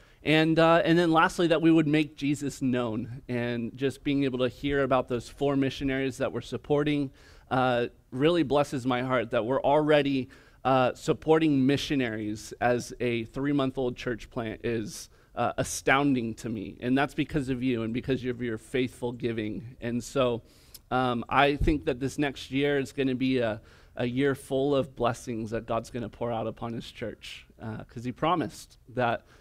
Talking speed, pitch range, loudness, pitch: 180 wpm, 120-140 Hz, -28 LUFS, 130 Hz